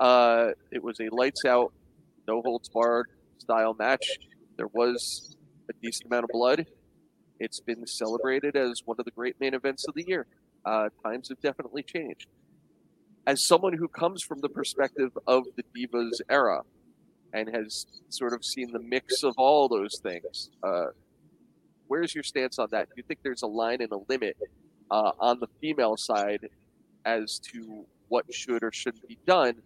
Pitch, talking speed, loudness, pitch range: 120 Hz, 175 wpm, -28 LUFS, 115-135 Hz